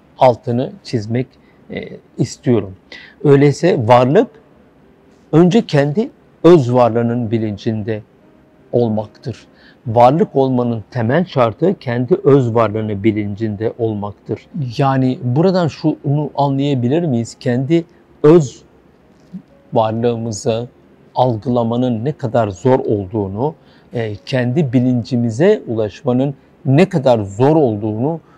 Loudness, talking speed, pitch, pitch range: -16 LUFS, 85 wpm, 125 Hz, 115-145 Hz